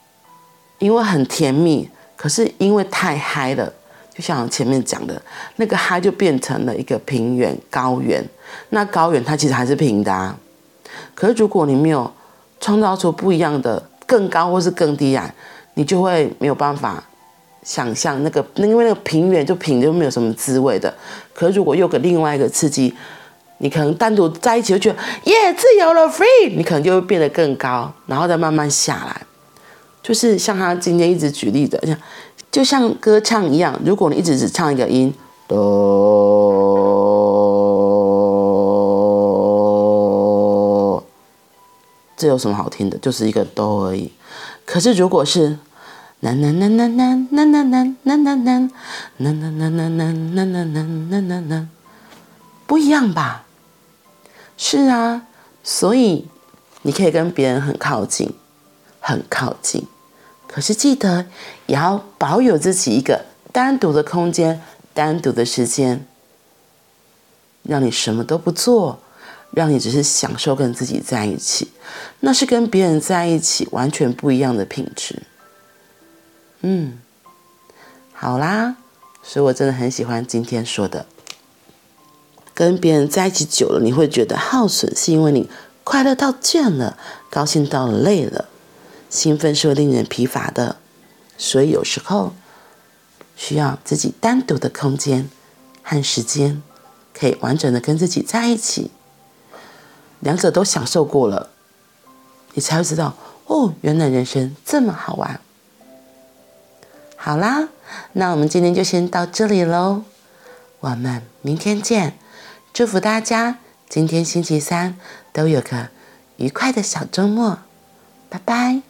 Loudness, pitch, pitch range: -17 LUFS, 160 Hz, 130-200 Hz